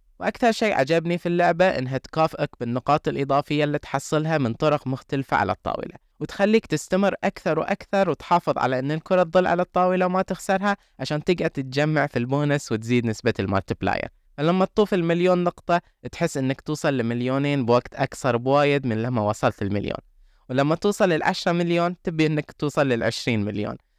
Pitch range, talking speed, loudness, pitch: 130-175 Hz, 155 wpm, -23 LUFS, 150 Hz